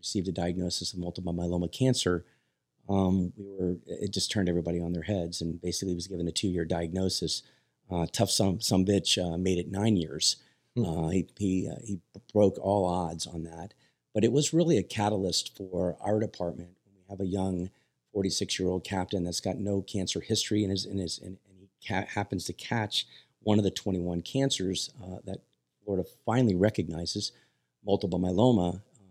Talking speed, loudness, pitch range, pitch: 180 wpm, -30 LUFS, 85-100 Hz, 95 Hz